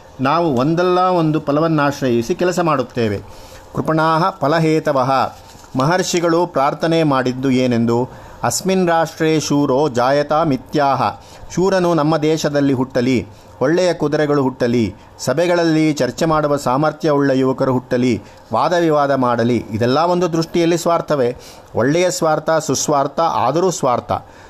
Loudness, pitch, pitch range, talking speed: -16 LUFS, 145 Hz, 125-165 Hz, 105 wpm